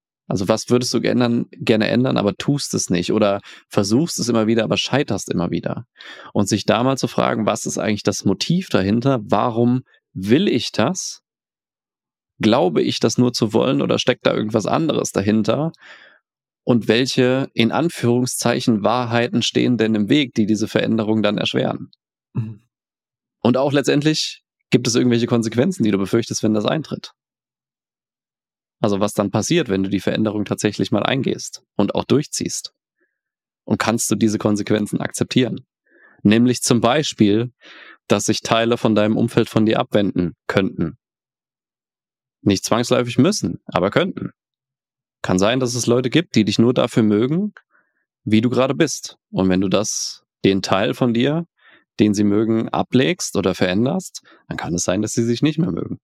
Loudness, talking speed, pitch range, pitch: -19 LUFS, 165 wpm, 105-125 Hz, 115 Hz